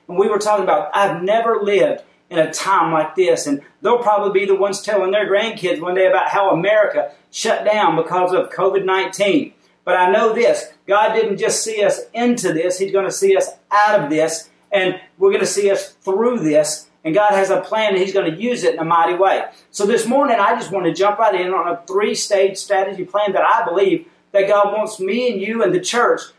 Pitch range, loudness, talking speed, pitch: 185-215 Hz, -17 LUFS, 230 wpm, 200 Hz